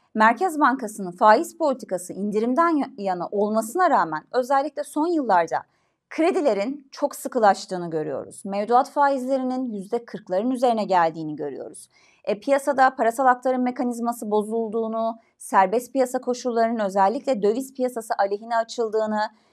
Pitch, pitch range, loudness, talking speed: 235 Hz, 205-265 Hz, -23 LUFS, 110 wpm